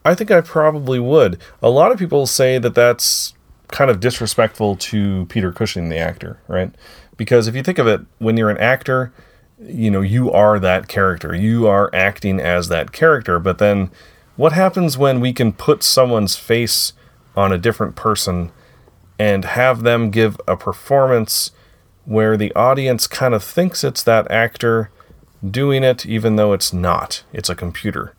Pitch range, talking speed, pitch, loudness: 95-125 Hz, 170 wpm, 110 Hz, -16 LUFS